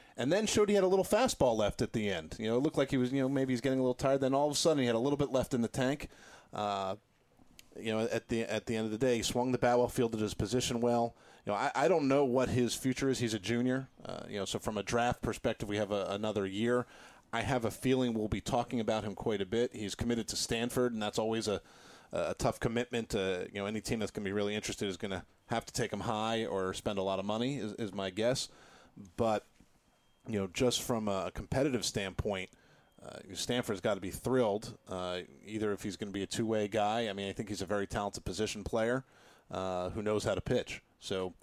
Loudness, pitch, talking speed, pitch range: -34 LUFS, 115 Hz, 260 wpm, 105-125 Hz